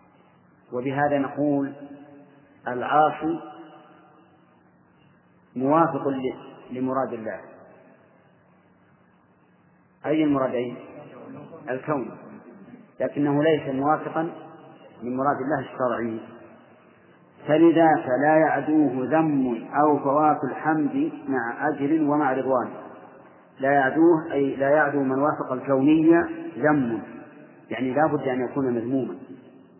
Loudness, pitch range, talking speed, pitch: -23 LUFS, 130-155 Hz, 85 wpm, 145 Hz